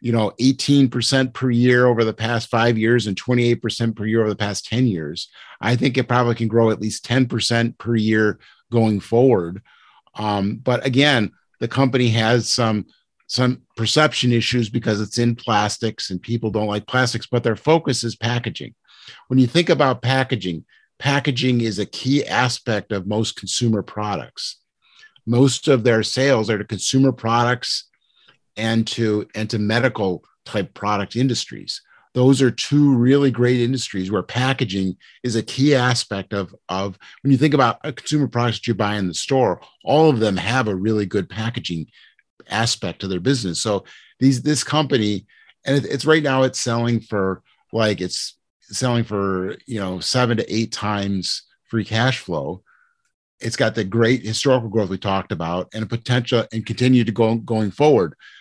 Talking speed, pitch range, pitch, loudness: 175 wpm, 105-130 Hz, 115 Hz, -20 LUFS